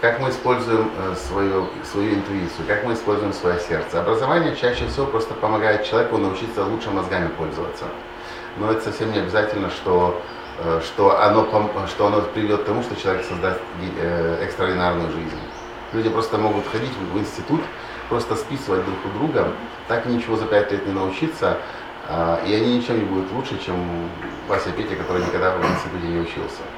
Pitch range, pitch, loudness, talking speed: 90-110 Hz, 105 Hz, -22 LUFS, 160 wpm